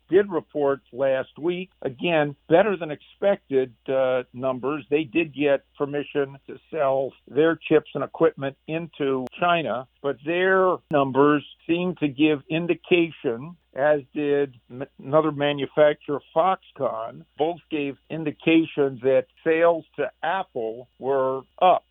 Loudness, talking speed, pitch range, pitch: -24 LUFS, 120 wpm, 135-160 Hz, 145 Hz